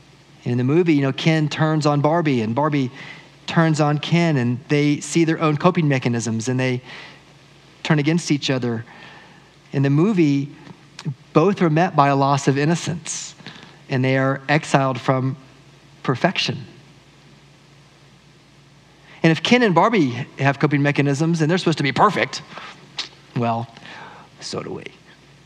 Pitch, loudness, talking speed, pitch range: 150 Hz, -19 LUFS, 145 wpm, 140-160 Hz